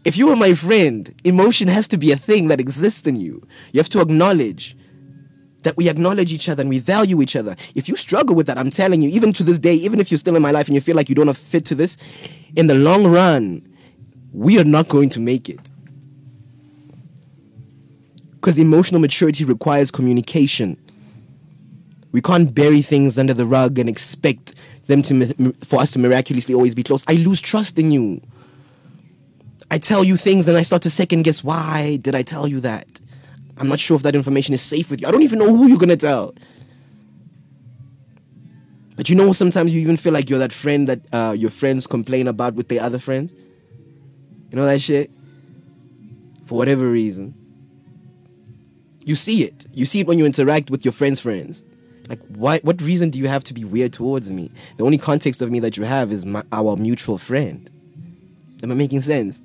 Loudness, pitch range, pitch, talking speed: -16 LUFS, 130-165 Hz, 145 Hz, 205 wpm